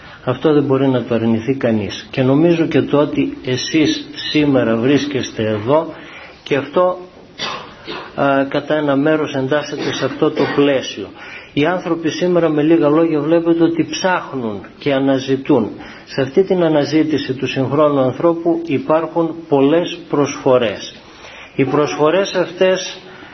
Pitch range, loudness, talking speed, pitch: 135-165 Hz, -16 LUFS, 130 wpm, 150 Hz